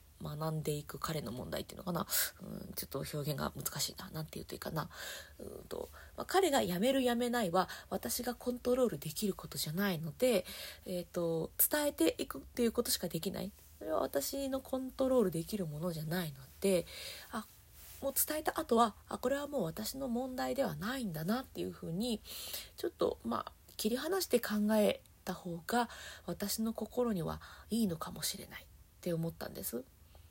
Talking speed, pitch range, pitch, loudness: 375 characters per minute, 165-250 Hz, 205 Hz, -36 LUFS